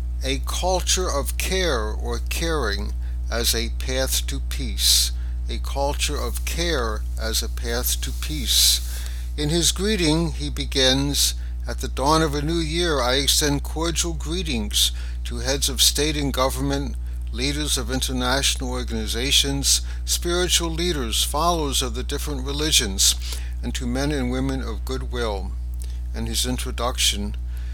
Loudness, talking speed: -22 LUFS, 140 wpm